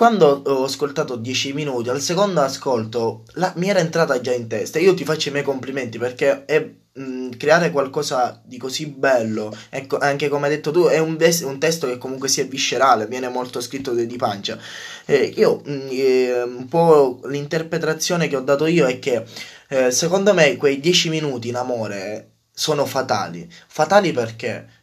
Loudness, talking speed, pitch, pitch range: -19 LUFS, 180 wpm, 140 Hz, 125-160 Hz